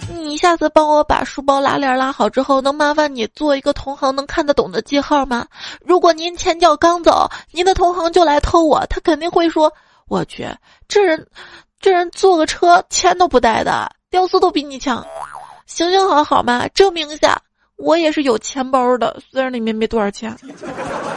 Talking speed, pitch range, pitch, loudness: 270 characters per minute, 265-350 Hz, 305 Hz, -15 LUFS